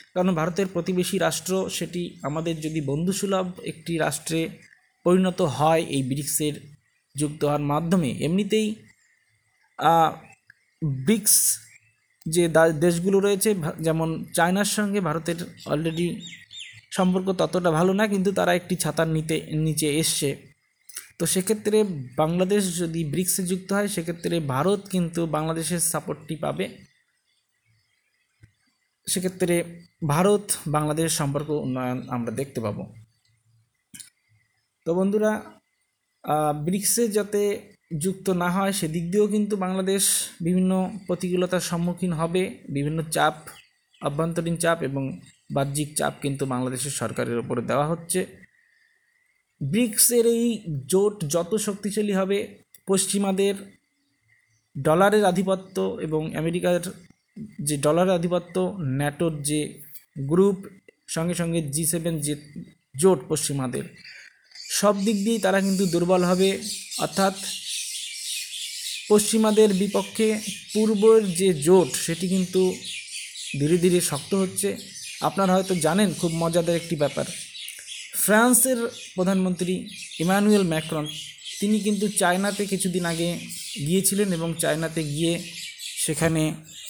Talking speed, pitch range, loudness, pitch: 105 wpm, 155-195 Hz, -24 LUFS, 175 Hz